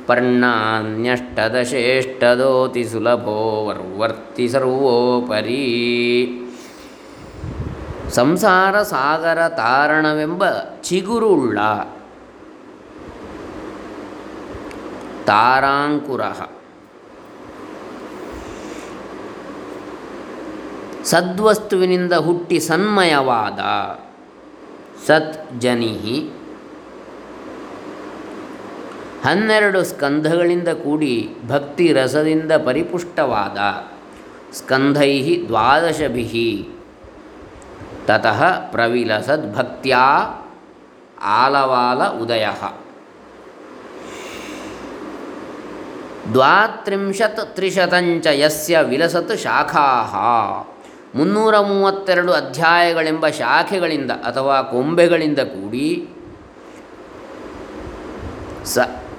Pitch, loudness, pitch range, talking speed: 155 Hz, -17 LUFS, 125-180 Hz, 35 wpm